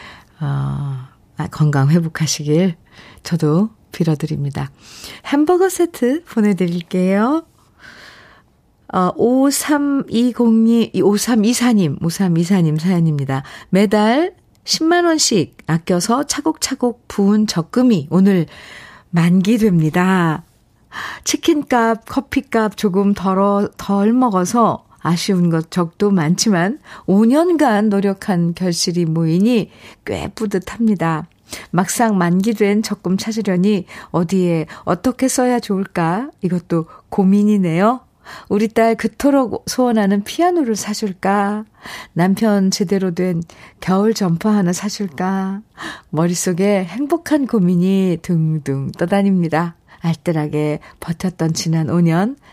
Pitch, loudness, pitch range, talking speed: 195 Hz, -17 LUFS, 170-225 Hz, 220 characters per minute